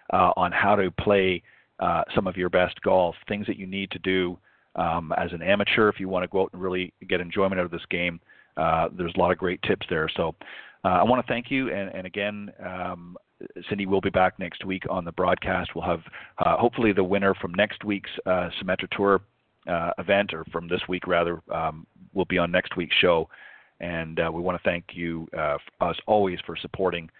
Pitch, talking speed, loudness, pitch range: 90 Hz, 225 wpm, -25 LUFS, 90-100 Hz